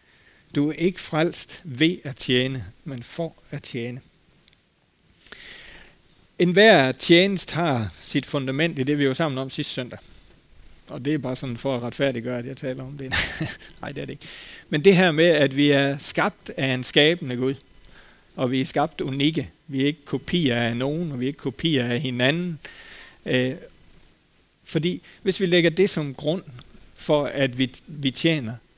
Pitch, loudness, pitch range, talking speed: 140 Hz, -23 LUFS, 130-165 Hz, 175 wpm